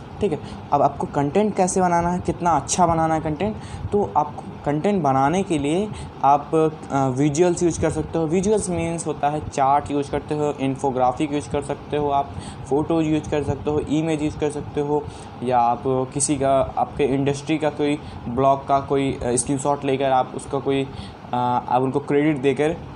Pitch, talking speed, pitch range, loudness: 145 Hz, 185 wpm, 135-155 Hz, -22 LUFS